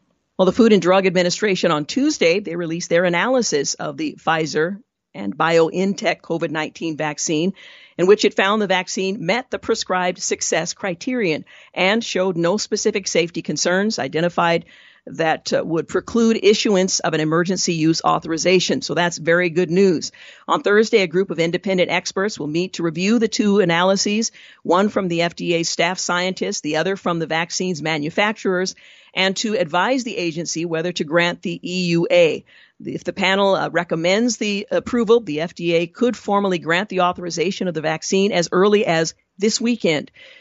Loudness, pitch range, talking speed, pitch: -19 LUFS, 170-205 Hz, 160 wpm, 185 Hz